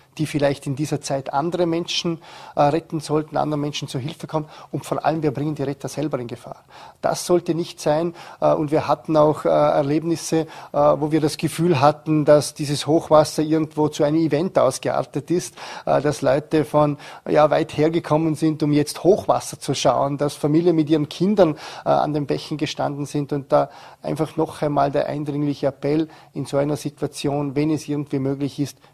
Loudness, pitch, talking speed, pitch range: -21 LUFS, 150 Hz, 180 wpm, 145-160 Hz